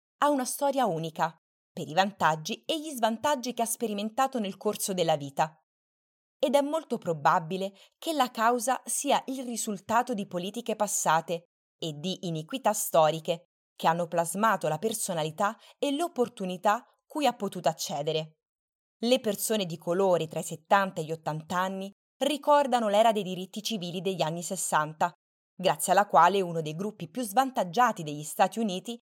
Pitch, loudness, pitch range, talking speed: 195 Hz, -28 LUFS, 170-235 Hz, 155 wpm